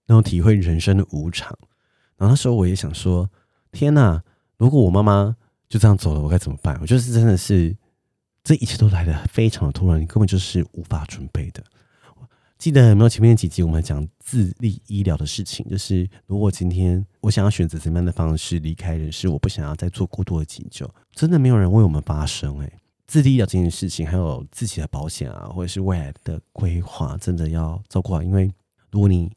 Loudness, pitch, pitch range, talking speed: -20 LUFS, 95 Hz, 85-110 Hz, 325 characters per minute